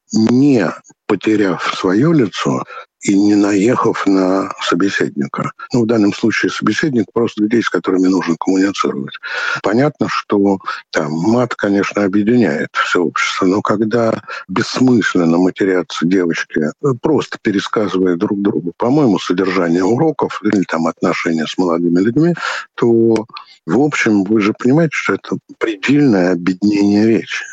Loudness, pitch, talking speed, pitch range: -15 LUFS, 105 Hz, 125 wpm, 95-115 Hz